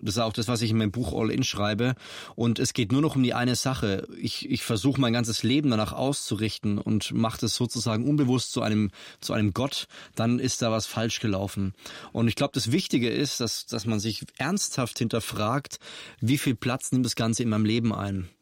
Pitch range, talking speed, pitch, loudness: 110-130 Hz, 220 wpm, 115 Hz, -27 LUFS